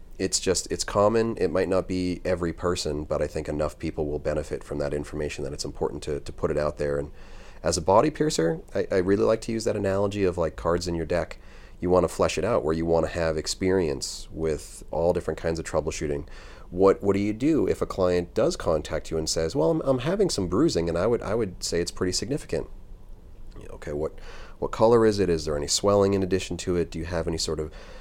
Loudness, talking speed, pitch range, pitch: -26 LUFS, 240 wpm, 80-100 Hz, 90 Hz